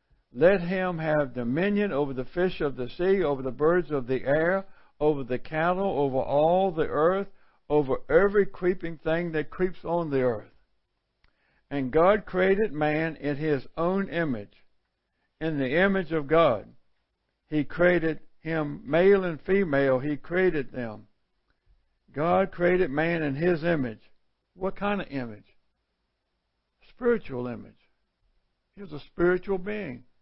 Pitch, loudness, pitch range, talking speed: 160 Hz, -26 LUFS, 140-185 Hz, 140 wpm